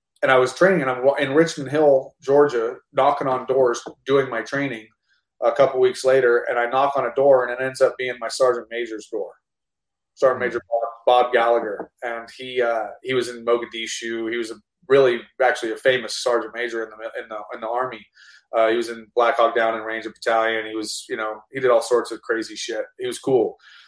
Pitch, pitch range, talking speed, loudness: 120 Hz, 115-135 Hz, 215 wpm, -21 LUFS